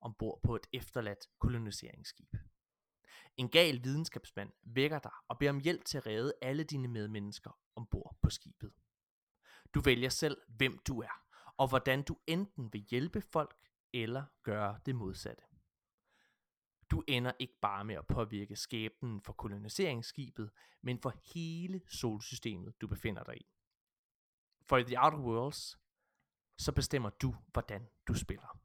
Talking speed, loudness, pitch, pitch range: 145 wpm, -37 LUFS, 125 Hz, 110-140 Hz